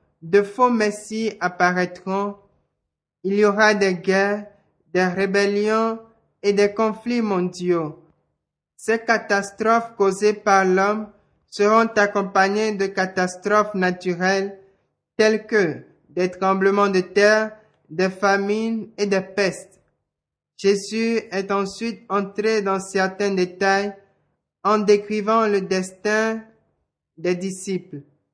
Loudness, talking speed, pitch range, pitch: -21 LUFS, 105 wpm, 190-215 Hz, 200 Hz